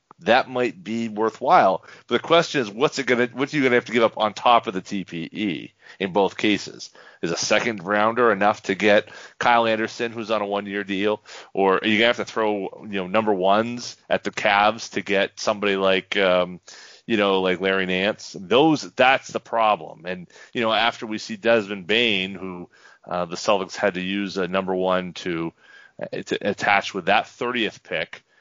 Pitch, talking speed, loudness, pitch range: 105 Hz, 200 wpm, -22 LUFS, 95-115 Hz